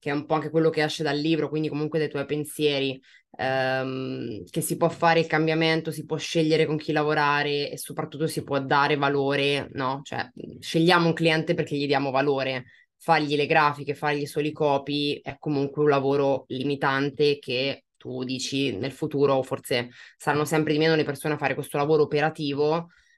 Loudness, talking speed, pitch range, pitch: -25 LUFS, 185 wpm, 140-155 Hz, 145 Hz